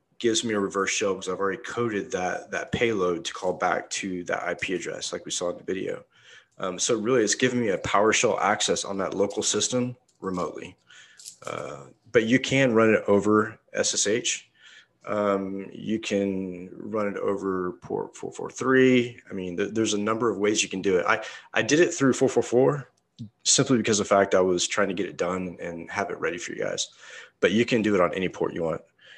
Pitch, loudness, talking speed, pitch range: 105 Hz, -25 LUFS, 220 wpm, 95-120 Hz